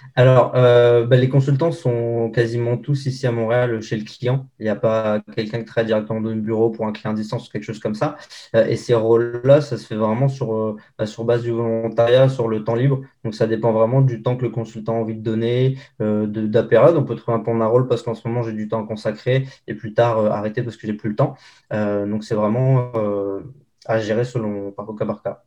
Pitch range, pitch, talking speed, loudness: 110-125 Hz, 115 Hz, 255 wpm, -19 LUFS